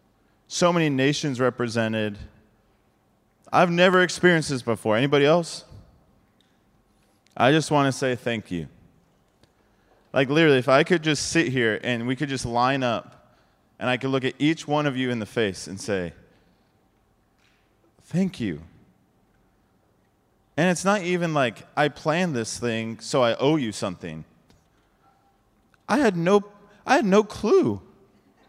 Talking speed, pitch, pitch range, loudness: 145 wpm, 125 Hz, 110-160 Hz, -23 LUFS